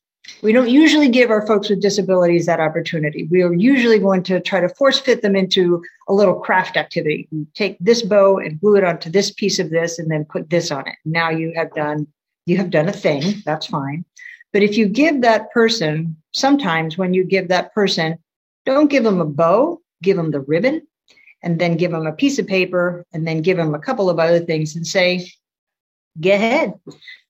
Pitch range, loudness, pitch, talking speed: 165-210 Hz, -17 LUFS, 180 Hz, 210 wpm